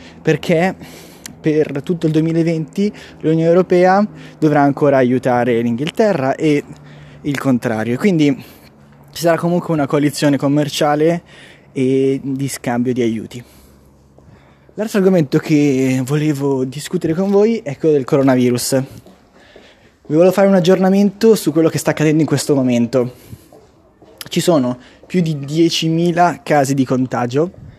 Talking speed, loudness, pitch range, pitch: 125 wpm, -15 LUFS, 130-165 Hz, 150 Hz